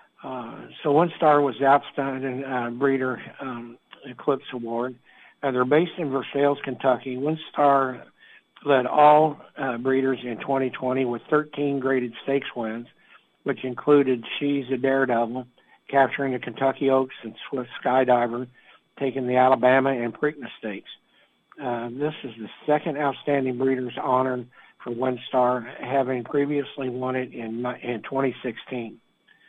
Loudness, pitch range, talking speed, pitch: -24 LUFS, 125-140 Hz, 140 wpm, 130 Hz